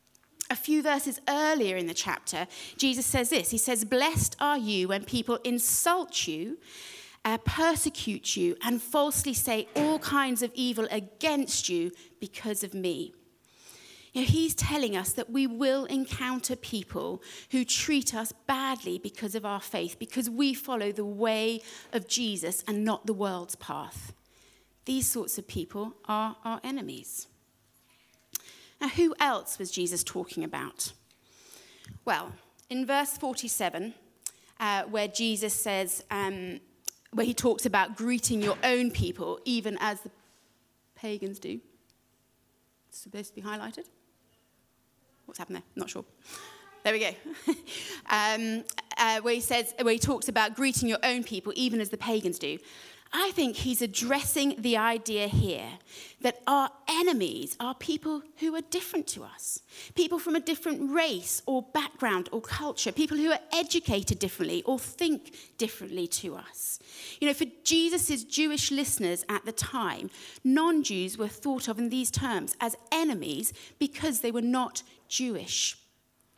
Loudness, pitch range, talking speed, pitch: -29 LUFS, 215-295 Hz, 150 wpm, 245 Hz